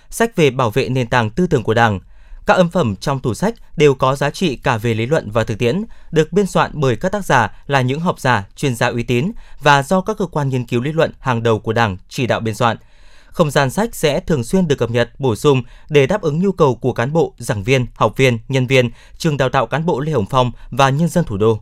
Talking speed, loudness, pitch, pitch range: 270 wpm, -17 LUFS, 135 Hz, 120-160 Hz